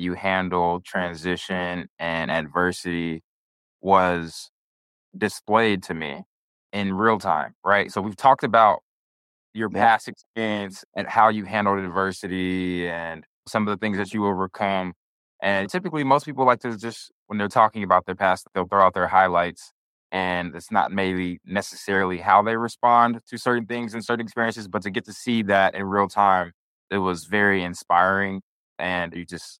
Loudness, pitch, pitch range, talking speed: -23 LUFS, 95 Hz, 90-105 Hz, 165 wpm